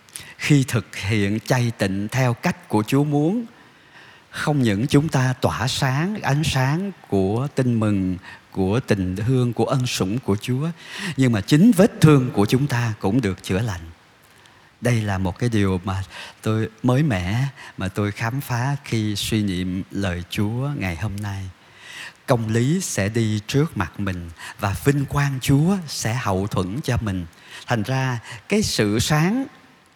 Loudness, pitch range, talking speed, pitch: -22 LUFS, 100-140 Hz, 165 wpm, 120 Hz